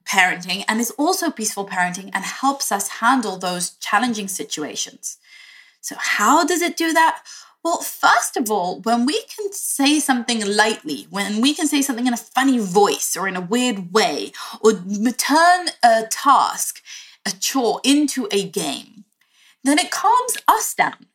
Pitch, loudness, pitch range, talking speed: 240 Hz, -19 LUFS, 200-295 Hz, 160 wpm